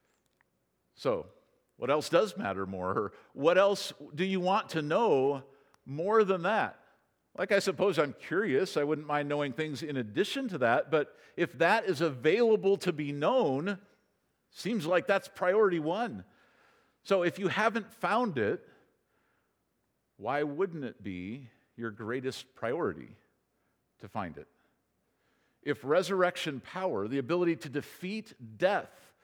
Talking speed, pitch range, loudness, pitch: 140 wpm, 140-195 Hz, -31 LUFS, 170 Hz